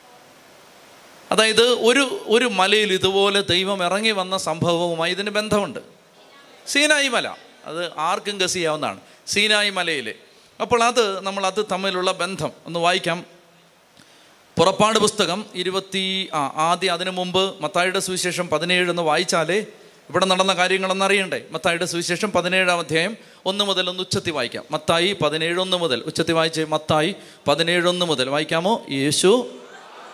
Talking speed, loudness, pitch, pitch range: 115 wpm, -20 LUFS, 185 Hz, 170-200 Hz